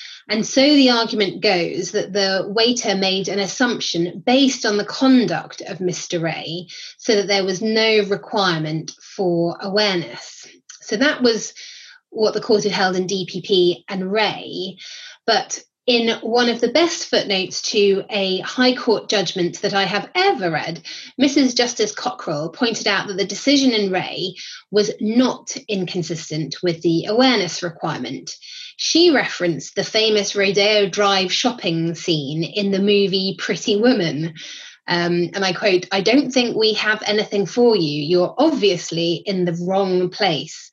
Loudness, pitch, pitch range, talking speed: -19 LUFS, 200 Hz, 180-225 Hz, 150 wpm